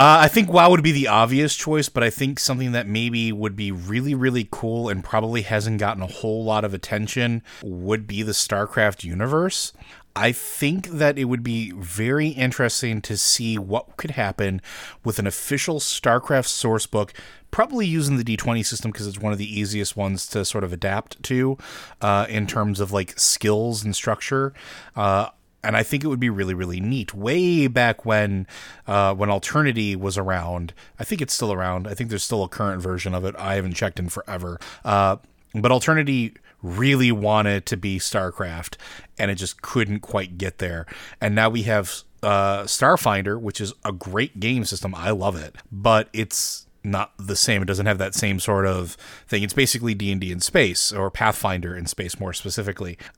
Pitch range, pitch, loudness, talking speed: 100-120 Hz, 105 Hz, -22 LUFS, 190 wpm